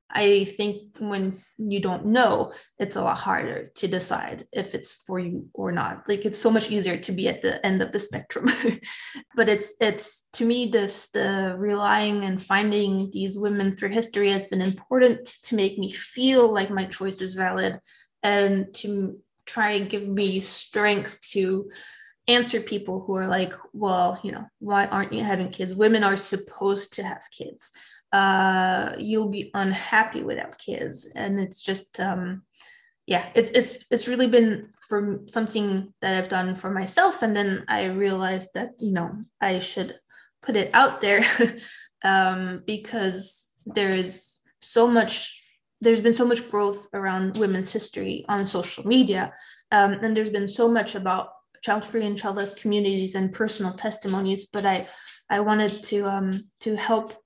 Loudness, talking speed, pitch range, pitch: -24 LUFS, 165 wpm, 195-220 Hz, 205 Hz